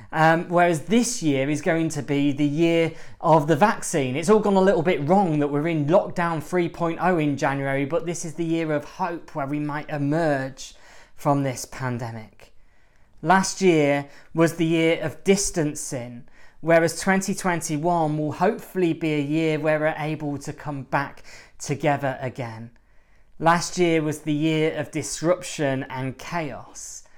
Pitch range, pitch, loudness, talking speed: 145-170 Hz, 155 Hz, -23 LUFS, 160 wpm